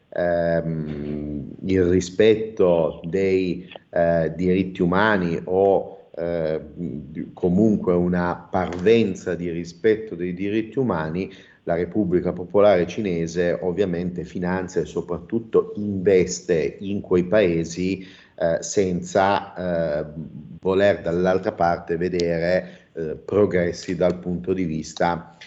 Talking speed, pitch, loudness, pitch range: 100 wpm, 90 Hz, -22 LUFS, 85-95 Hz